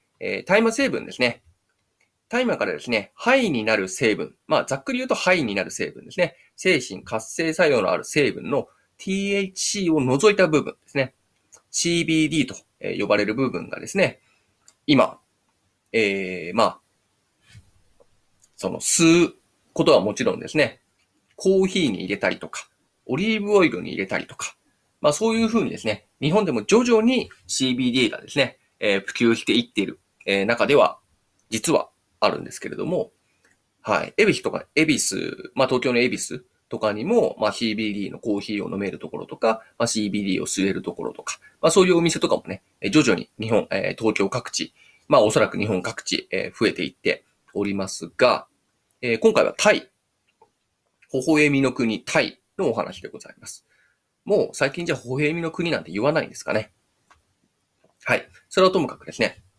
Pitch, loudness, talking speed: 135 Hz, -22 LUFS, 335 characters per minute